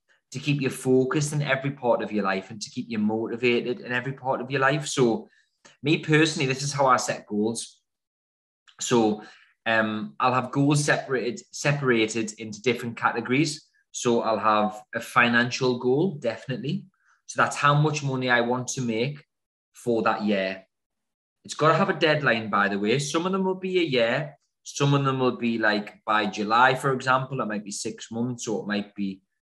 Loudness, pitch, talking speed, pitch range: -25 LUFS, 125 Hz, 190 wpm, 110-140 Hz